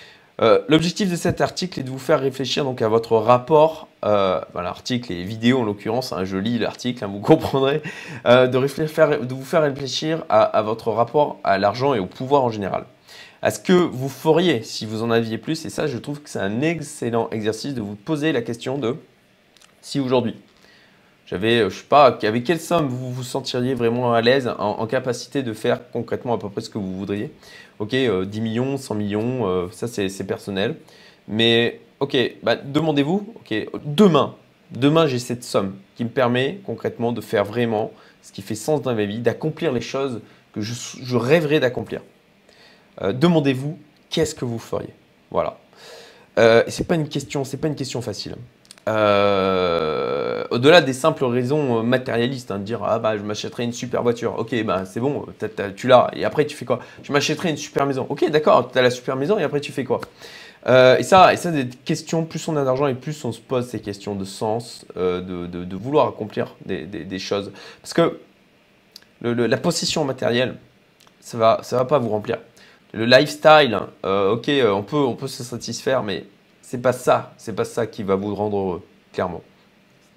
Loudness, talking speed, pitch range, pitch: -21 LUFS, 205 wpm, 110-150 Hz, 125 Hz